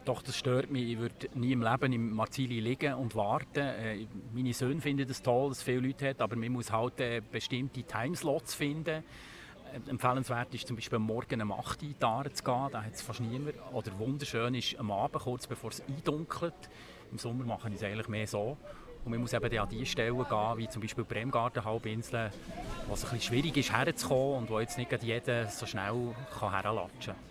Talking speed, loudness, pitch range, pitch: 200 wpm, -35 LUFS, 110-130 Hz, 120 Hz